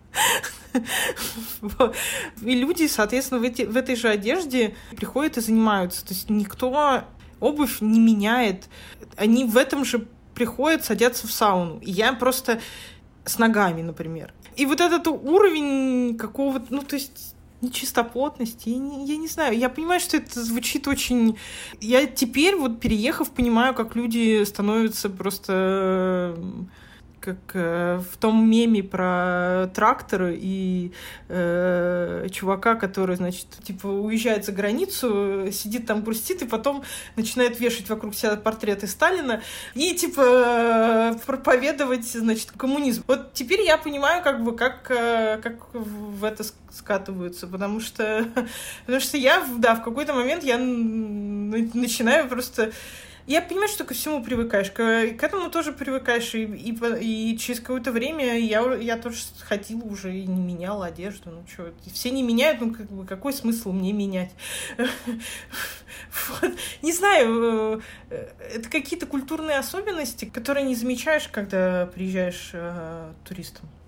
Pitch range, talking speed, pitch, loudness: 205-265 Hz, 135 wpm, 230 Hz, -23 LUFS